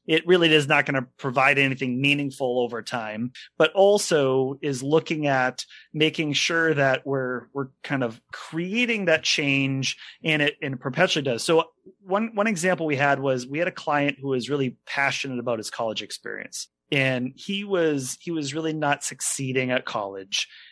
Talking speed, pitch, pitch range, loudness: 175 wpm, 145 Hz, 130-160 Hz, -24 LUFS